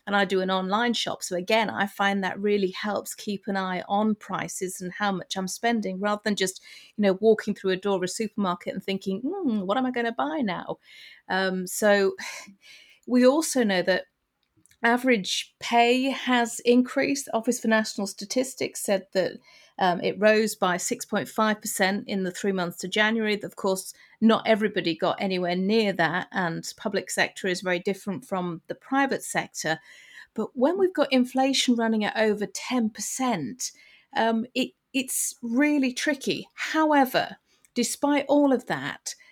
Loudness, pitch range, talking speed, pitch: -25 LUFS, 190-245 Hz, 170 wpm, 210 Hz